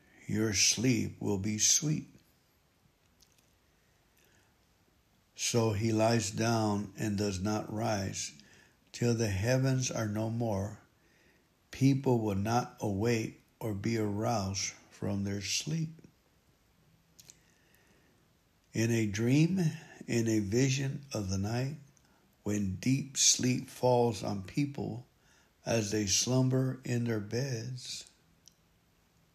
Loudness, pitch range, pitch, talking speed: -31 LUFS, 105-125 Hz, 115 Hz, 100 wpm